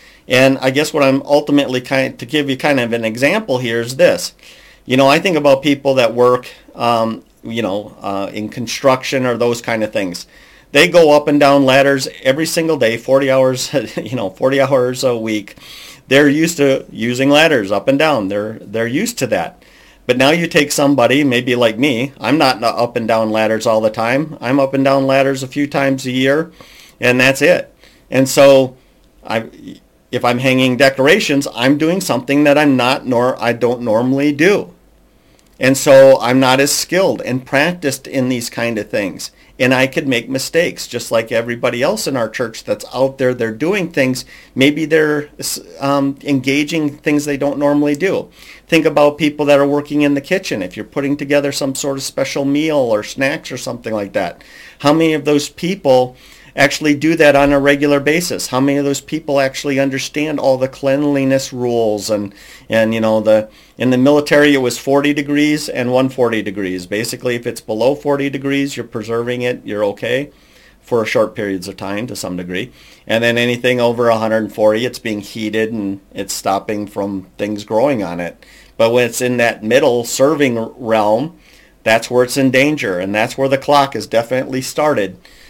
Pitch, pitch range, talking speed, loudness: 130 Hz, 120-145 Hz, 190 wpm, -15 LUFS